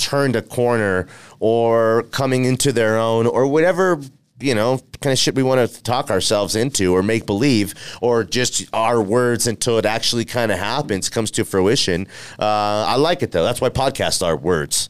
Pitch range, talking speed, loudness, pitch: 105-130 Hz, 190 wpm, -18 LUFS, 115 Hz